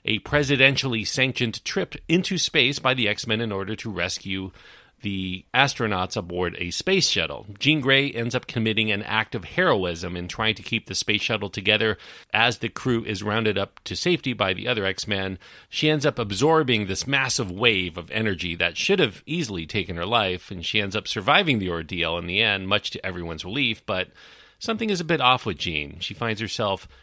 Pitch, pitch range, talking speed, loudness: 110 Hz, 95-125 Hz, 200 wpm, -23 LUFS